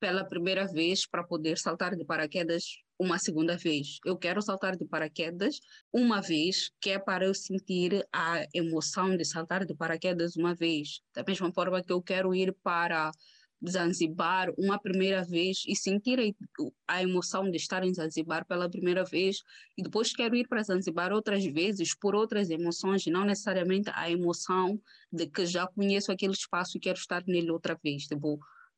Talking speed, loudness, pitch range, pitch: 170 wpm, -31 LUFS, 170-195 Hz, 185 Hz